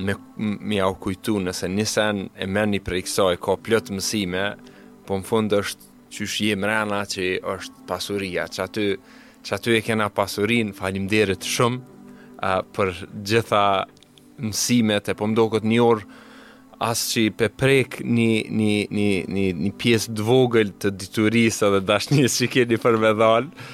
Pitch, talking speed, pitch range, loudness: 105 Hz, 155 wpm, 100-115 Hz, -22 LUFS